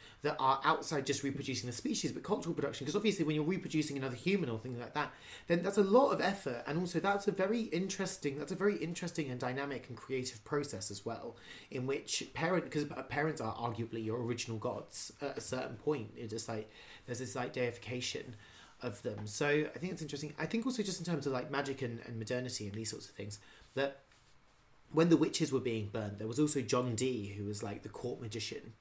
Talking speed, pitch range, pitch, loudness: 225 wpm, 115-160 Hz, 135 Hz, -36 LUFS